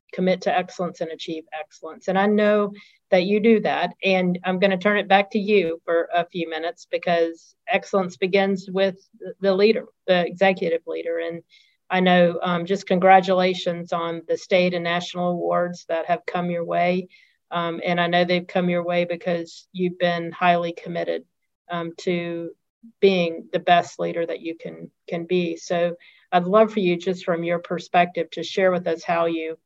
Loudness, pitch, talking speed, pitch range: -22 LUFS, 180 Hz, 185 wpm, 170-190 Hz